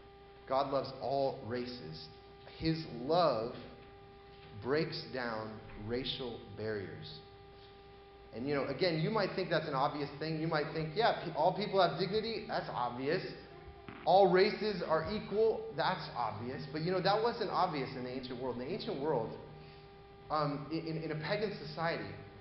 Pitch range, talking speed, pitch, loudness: 130-170 Hz, 155 wpm, 135 Hz, -35 LUFS